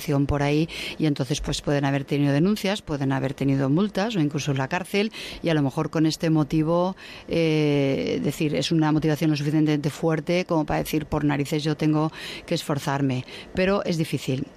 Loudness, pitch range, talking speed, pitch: -24 LUFS, 145-165 Hz, 185 wpm, 155 Hz